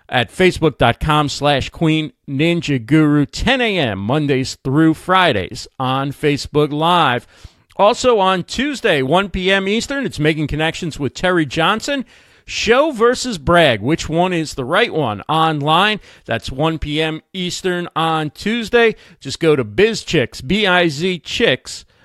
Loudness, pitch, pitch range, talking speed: -16 LUFS, 160 Hz, 145-185 Hz, 130 wpm